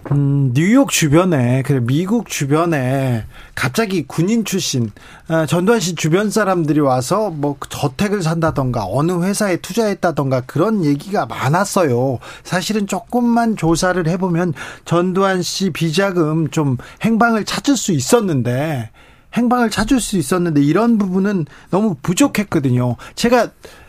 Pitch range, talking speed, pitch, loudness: 145-205 Hz, 290 characters per minute, 170 Hz, -17 LUFS